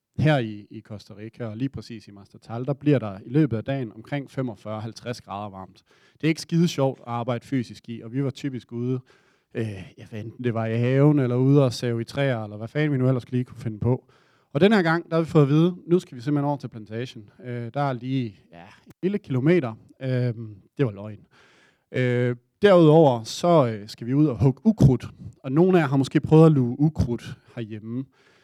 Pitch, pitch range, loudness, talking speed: 125 Hz, 115-145 Hz, -23 LUFS, 225 wpm